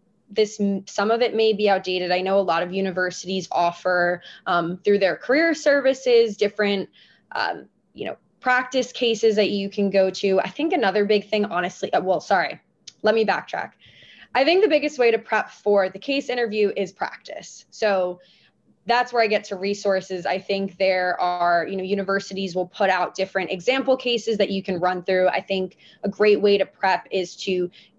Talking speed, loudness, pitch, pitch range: 190 wpm, -22 LUFS, 200 Hz, 185-220 Hz